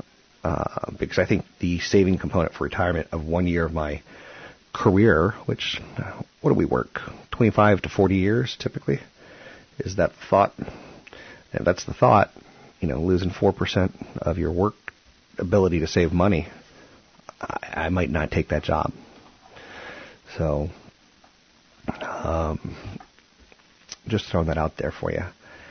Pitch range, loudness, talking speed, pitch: 80-95 Hz, -24 LUFS, 140 wpm, 90 Hz